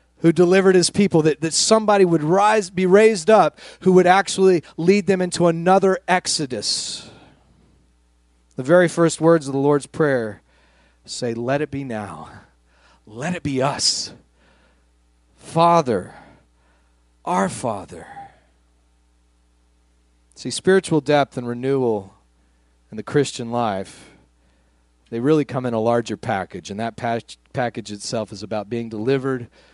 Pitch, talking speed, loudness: 120 Hz, 130 wpm, -19 LUFS